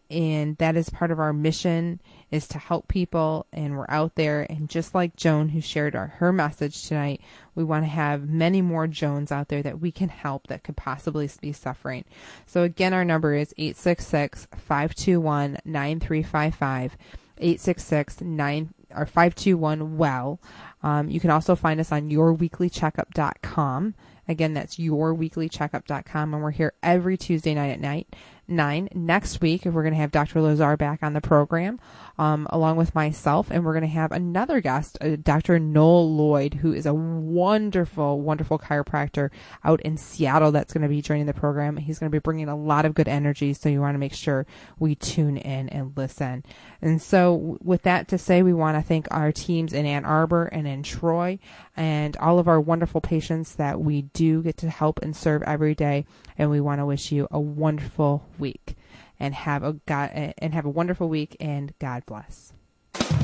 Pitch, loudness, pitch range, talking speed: 155 Hz, -24 LUFS, 145-165 Hz, 185 wpm